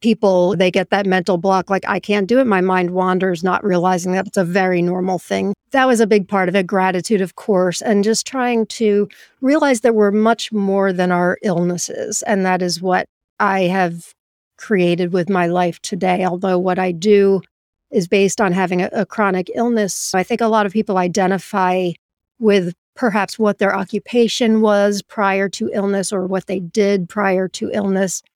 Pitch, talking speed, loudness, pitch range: 195 Hz, 190 wpm, -17 LUFS, 185-210 Hz